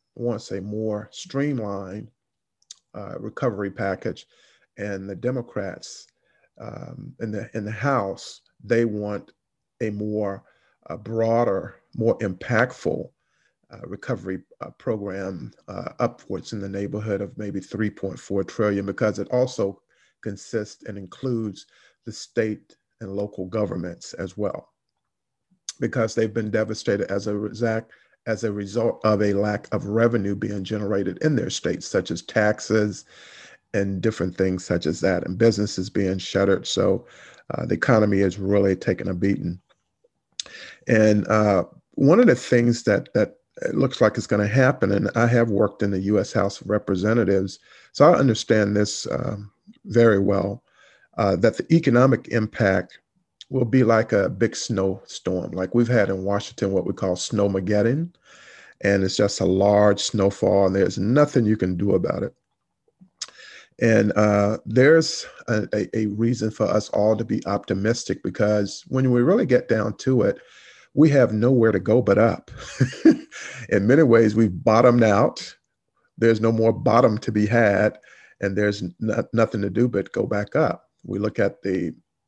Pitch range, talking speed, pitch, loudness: 100-115 Hz, 155 wpm, 105 Hz, -22 LUFS